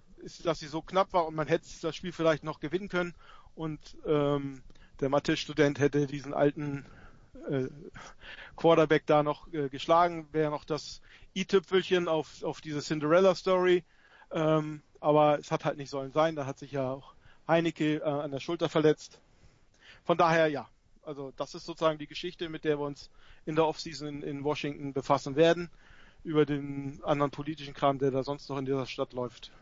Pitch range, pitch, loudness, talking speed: 140-165 Hz, 150 Hz, -30 LUFS, 180 wpm